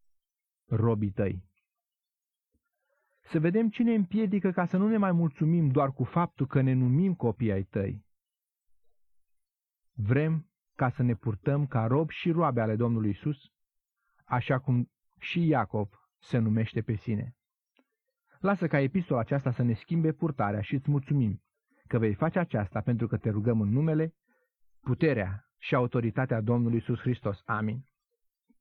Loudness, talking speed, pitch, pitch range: -29 LUFS, 145 wpm, 130 Hz, 115-165 Hz